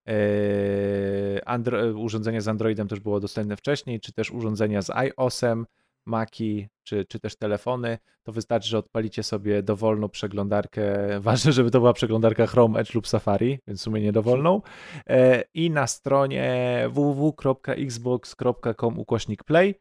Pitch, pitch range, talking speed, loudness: 115 Hz, 105-125 Hz, 125 wpm, -24 LUFS